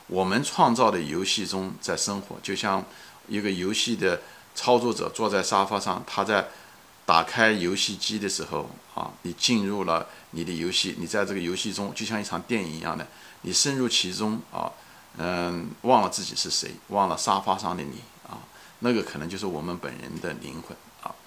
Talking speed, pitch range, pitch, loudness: 270 characters per minute, 90-110 Hz, 100 Hz, -26 LUFS